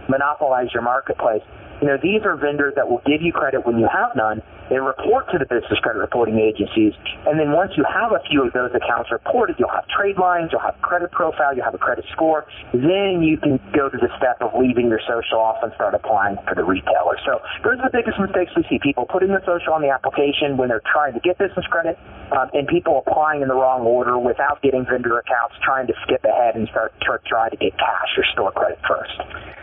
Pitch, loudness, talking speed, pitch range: 140 Hz, -19 LUFS, 235 wpm, 120-175 Hz